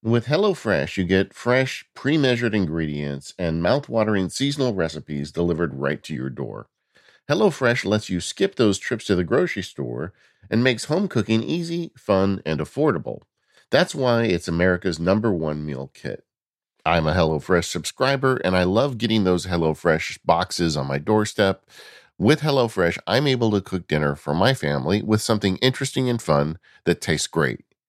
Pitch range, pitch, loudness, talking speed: 80-125 Hz, 100 Hz, -22 LUFS, 160 wpm